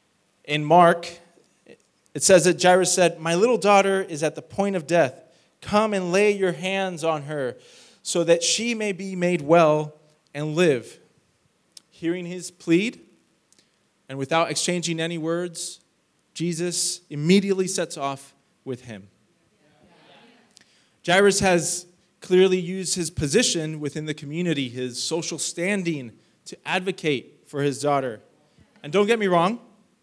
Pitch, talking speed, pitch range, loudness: 175 Hz, 135 wpm, 155-190 Hz, -22 LUFS